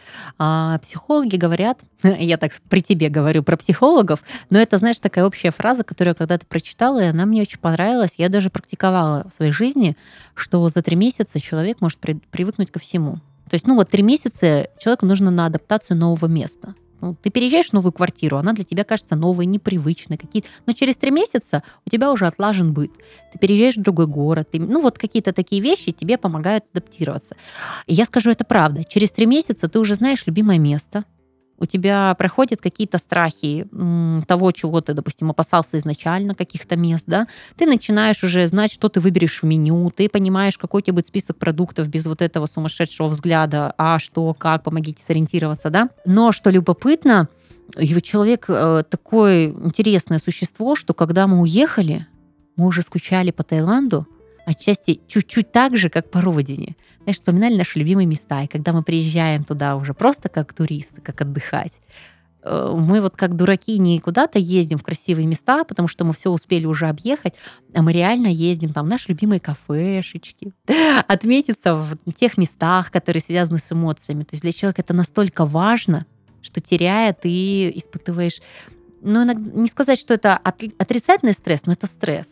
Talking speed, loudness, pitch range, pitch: 170 wpm, -18 LUFS, 160-205 Hz, 180 Hz